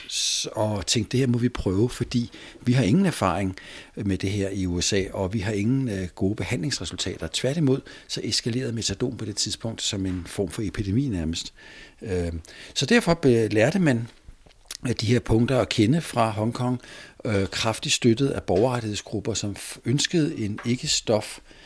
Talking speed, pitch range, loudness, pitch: 160 wpm, 100-130 Hz, -25 LUFS, 115 Hz